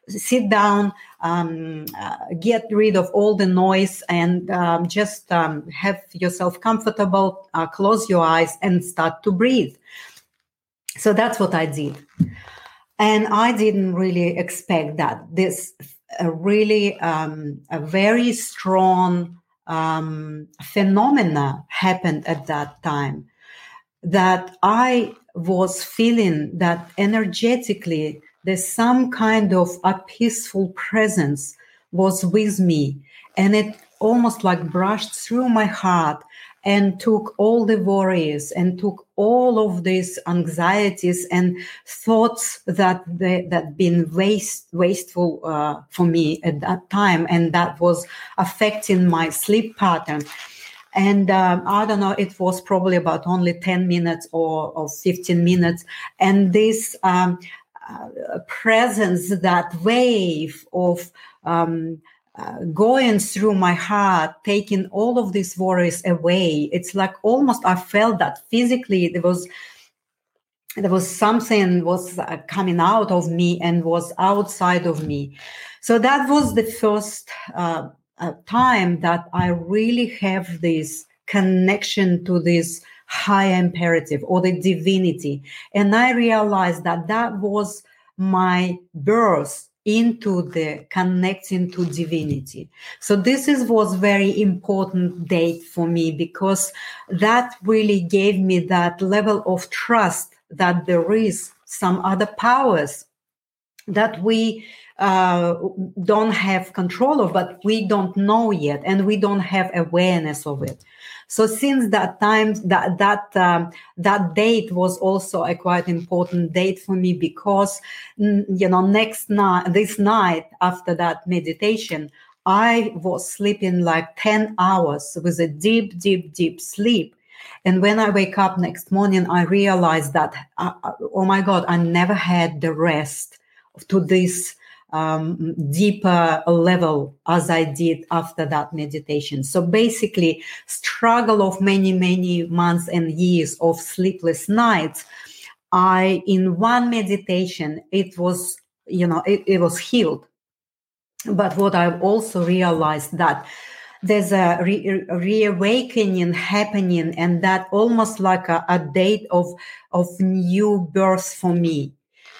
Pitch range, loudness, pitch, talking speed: 170-205 Hz, -19 LUFS, 185 Hz, 130 wpm